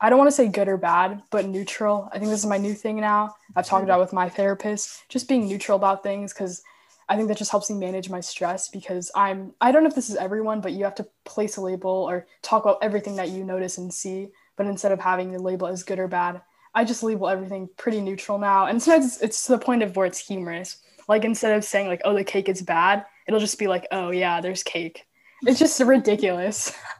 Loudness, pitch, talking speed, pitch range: -23 LUFS, 200 Hz, 250 wpm, 185-215 Hz